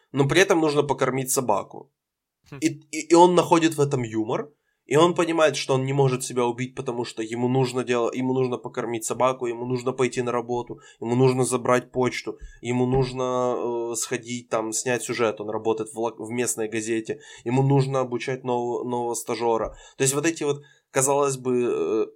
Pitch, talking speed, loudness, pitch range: 125 Hz, 185 wpm, -24 LUFS, 120-140 Hz